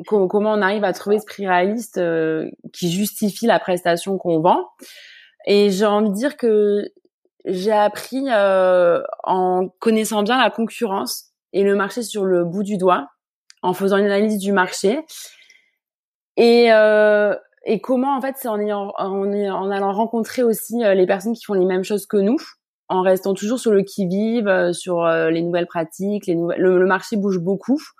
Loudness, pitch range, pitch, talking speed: -19 LUFS, 185-225 Hz, 200 Hz, 180 wpm